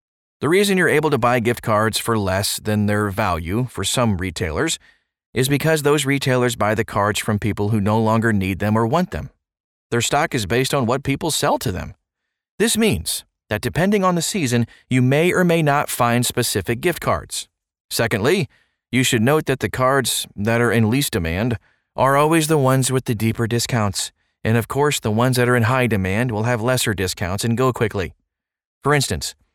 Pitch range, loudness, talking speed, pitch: 105-135 Hz, -19 LUFS, 200 wpm, 120 Hz